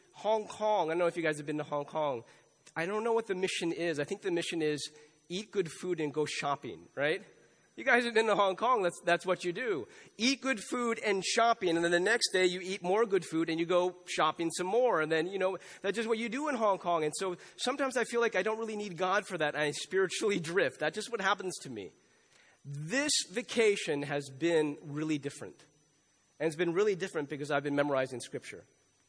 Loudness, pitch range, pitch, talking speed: -32 LUFS, 155-210 Hz, 180 Hz, 235 wpm